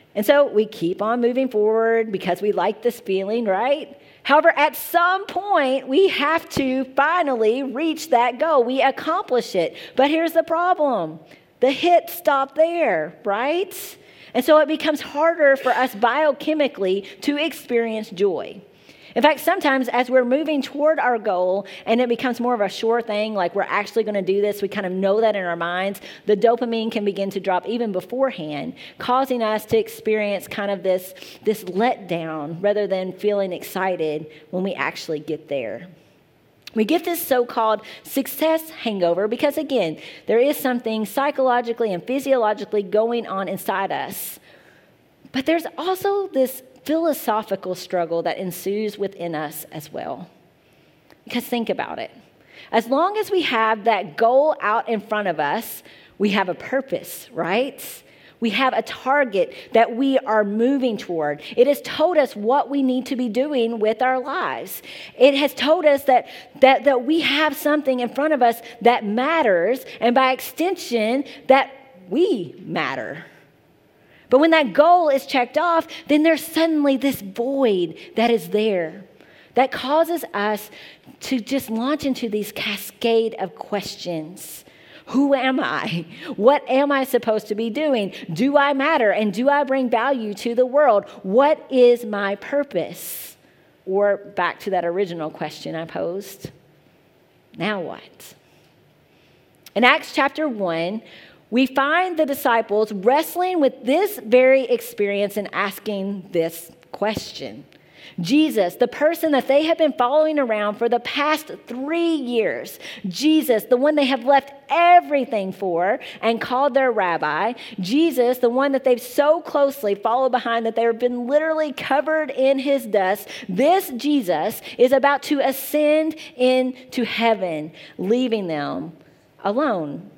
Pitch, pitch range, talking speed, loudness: 245 Hz, 205-285 Hz, 155 wpm, -20 LUFS